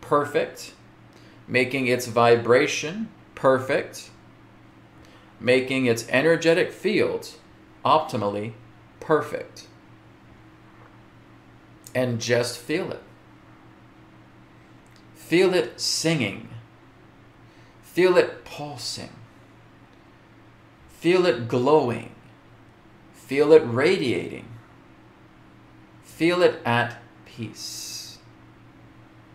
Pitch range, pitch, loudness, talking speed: 115-150 Hz, 120 Hz, -23 LUFS, 65 wpm